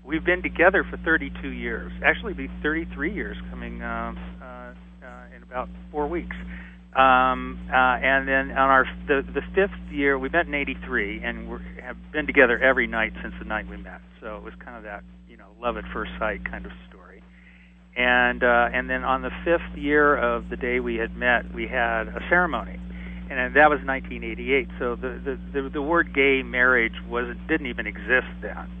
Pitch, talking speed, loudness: 90 Hz, 200 wpm, -23 LUFS